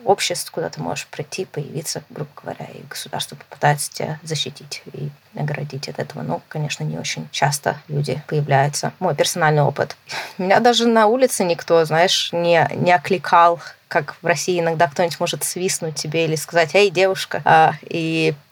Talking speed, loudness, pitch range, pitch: 160 wpm, -19 LUFS, 145-175 Hz, 165 Hz